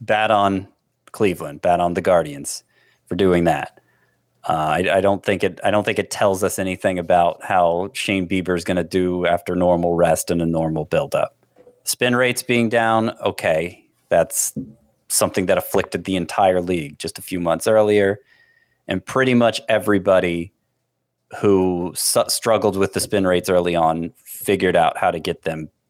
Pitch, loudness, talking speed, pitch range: 95 Hz, -19 LUFS, 170 wpm, 85-105 Hz